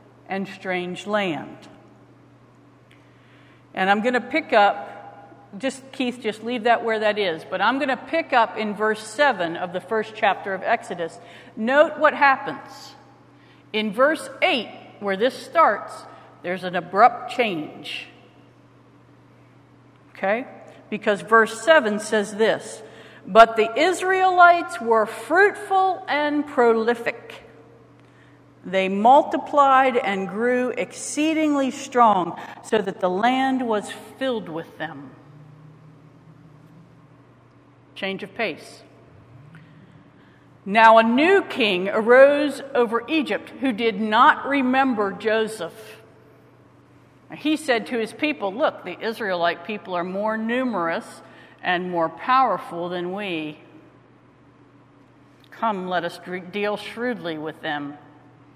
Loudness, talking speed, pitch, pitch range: -21 LUFS, 115 wpm, 215 Hz, 170-255 Hz